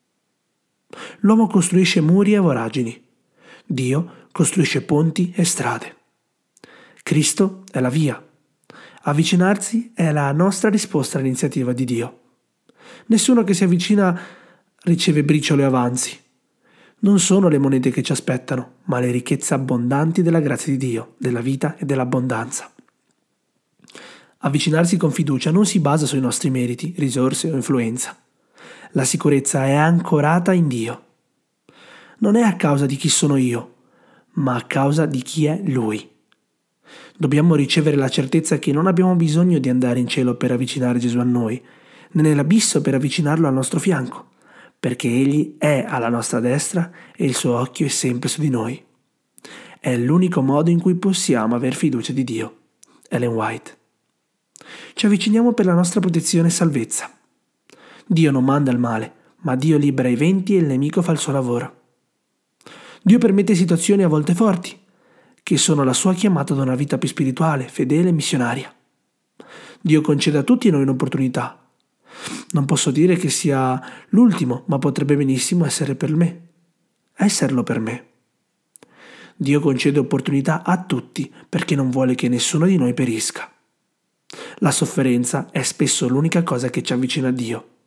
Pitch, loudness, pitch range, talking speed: 150 Hz, -18 LUFS, 130-175 Hz, 150 wpm